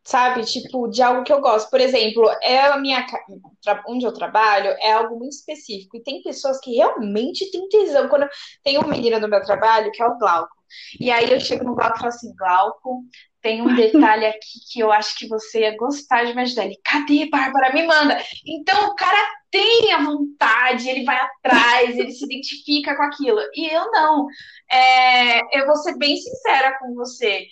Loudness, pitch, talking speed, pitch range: -18 LUFS, 255 Hz, 200 wpm, 230-290 Hz